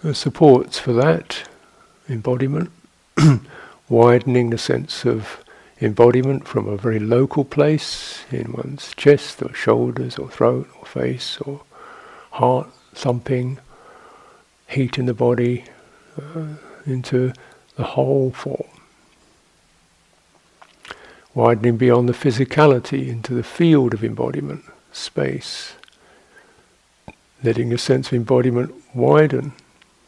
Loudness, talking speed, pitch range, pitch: -19 LUFS, 100 wpm, 120-145 Hz, 125 Hz